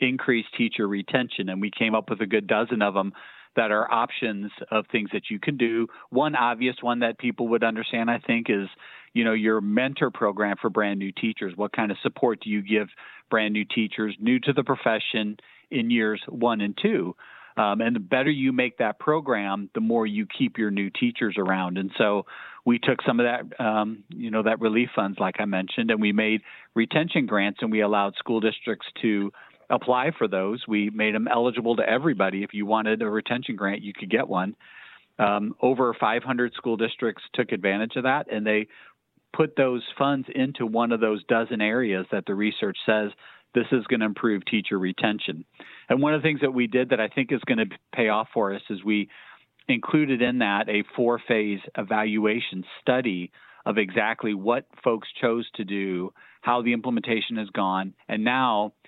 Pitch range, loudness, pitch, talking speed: 105-120 Hz, -25 LUFS, 110 Hz, 200 wpm